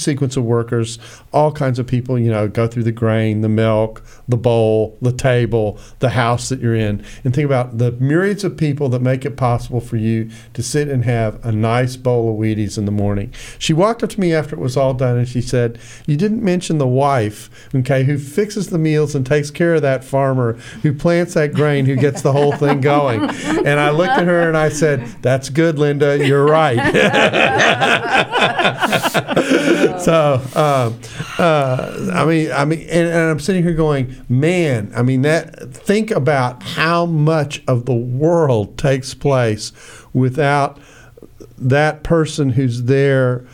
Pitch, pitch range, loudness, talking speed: 135 Hz, 120-150 Hz, -16 LUFS, 180 wpm